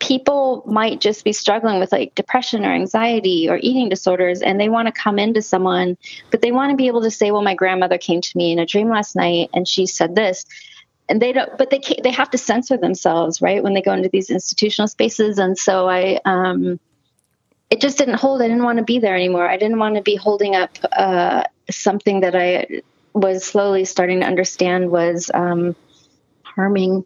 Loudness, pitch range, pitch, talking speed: -17 LUFS, 185-225 Hz, 200 Hz, 215 wpm